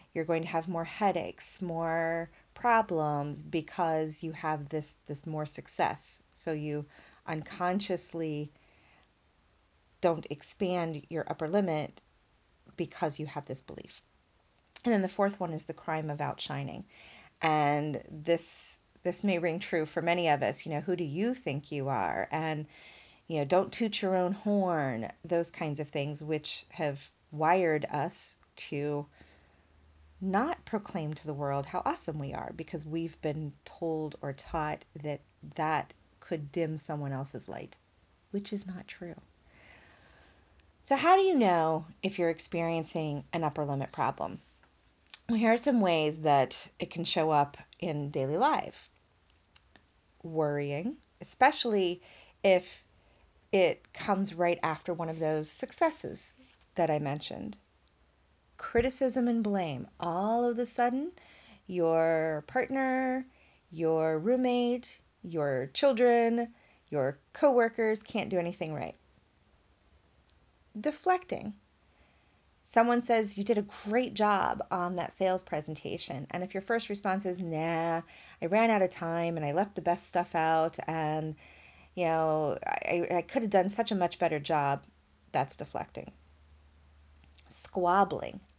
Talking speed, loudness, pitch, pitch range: 140 wpm, -31 LUFS, 165 Hz, 145-190 Hz